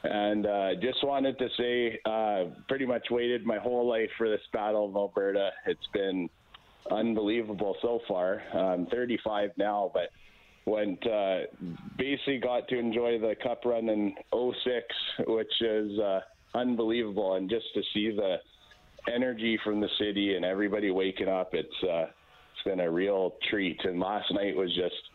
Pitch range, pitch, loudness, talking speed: 100-120 Hz, 110 Hz, -30 LUFS, 160 wpm